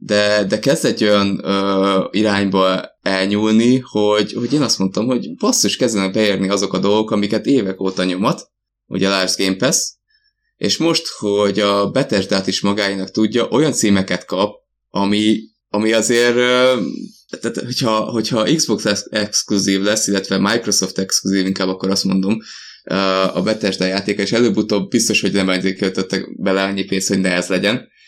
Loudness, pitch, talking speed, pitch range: -17 LUFS, 100 Hz, 155 wpm, 95-110 Hz